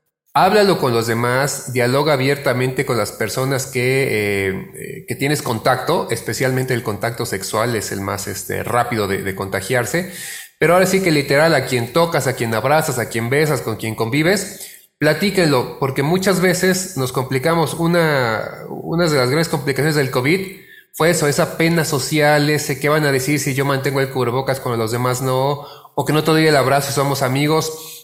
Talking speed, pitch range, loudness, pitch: 180 wpm, 125-160 Hz, -17 LUFS, 140 Hz